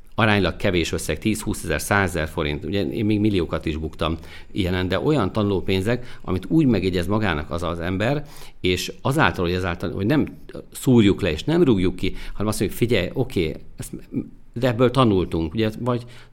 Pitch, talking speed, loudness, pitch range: 95 Hz, 175 wpm, -22 LUFS, 85-110 Hz